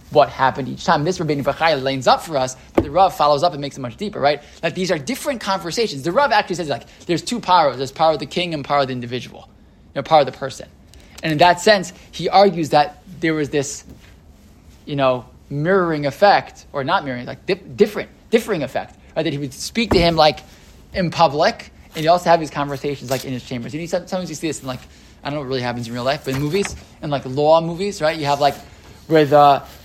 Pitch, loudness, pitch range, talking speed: 150 Hz, -19 LUFS, 135-175 Hz, 245 wpm